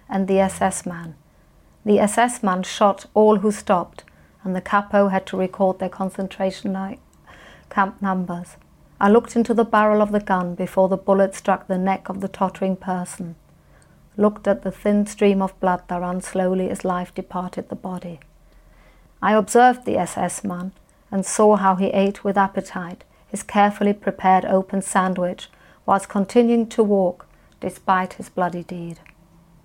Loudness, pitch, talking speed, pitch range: -20 LUFS, 190 Hz, 160 wpm, 185-205 Hz